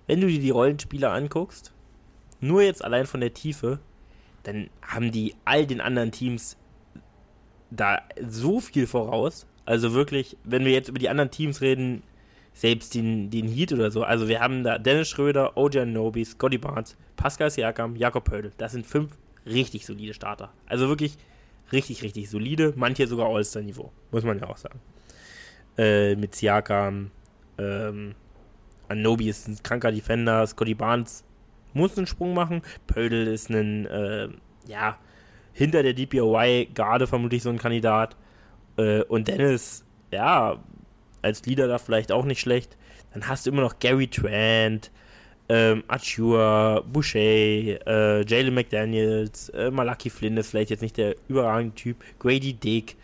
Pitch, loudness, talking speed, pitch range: 115 Hz, -25 LUFS, 155 wpm, 110-130 Hz